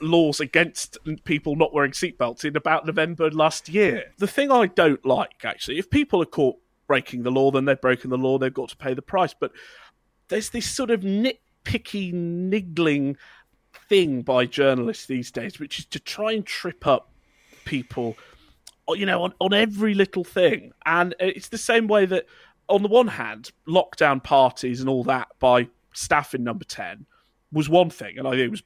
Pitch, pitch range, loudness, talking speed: 160 Hz, 135-200 Hz, -23 LUFS, 190 wpm